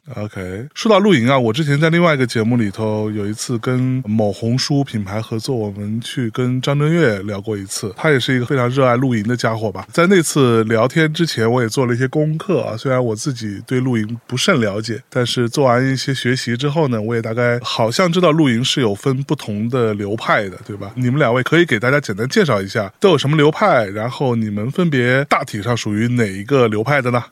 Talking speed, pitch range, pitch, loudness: 340 characters per minute, 110-140 Hz, 125 Hz, -17 LUFS